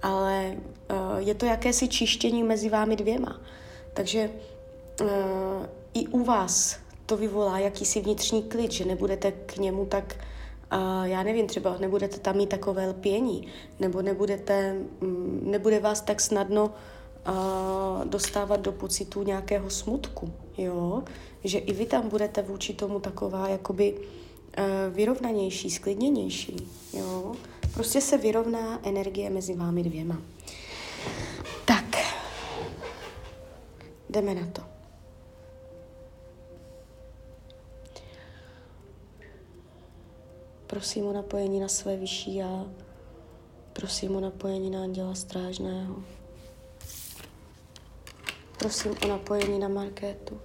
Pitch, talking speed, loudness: 195 Hz, 105 wpm, -29 LUFS